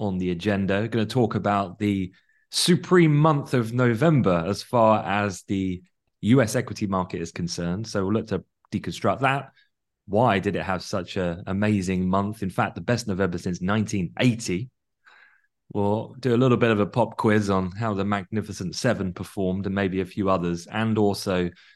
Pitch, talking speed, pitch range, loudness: 100 Hz, 180 wpm, 95-115 Hz, -24 LUFS